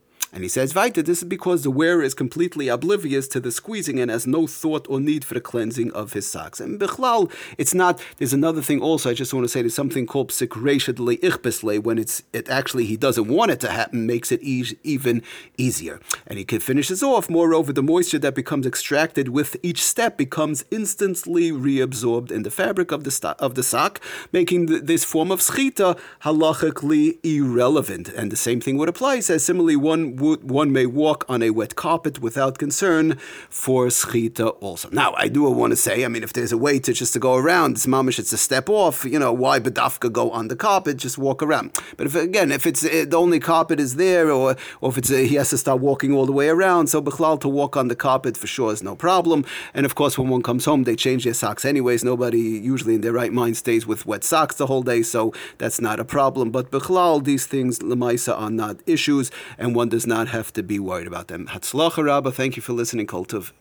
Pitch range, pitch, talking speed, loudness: 120-160 Hz, 135 Hz, 225 wpm, -21 LUFS